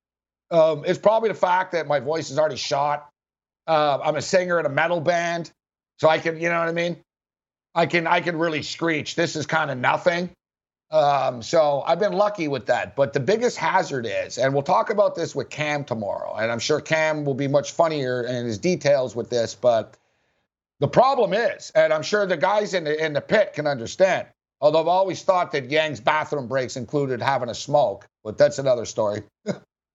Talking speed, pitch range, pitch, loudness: 205 wpm, 140-175 Hz, 155 Hz, -22 LUFS